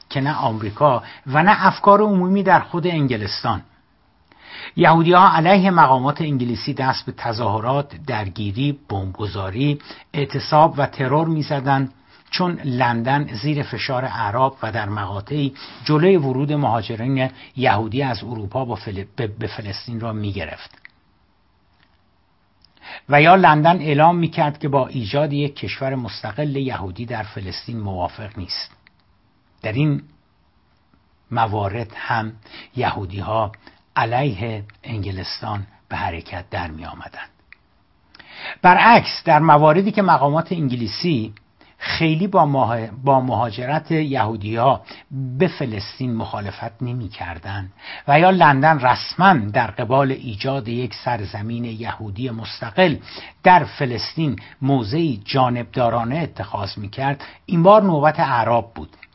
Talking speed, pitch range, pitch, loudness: 110 wpm, 105-145 Hz, 125 Hz, -19 LUFS